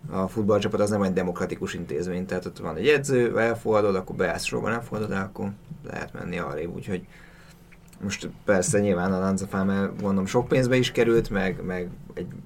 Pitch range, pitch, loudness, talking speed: 95-115 Hz, 100 Hz, -25 LUFS, 165 wpm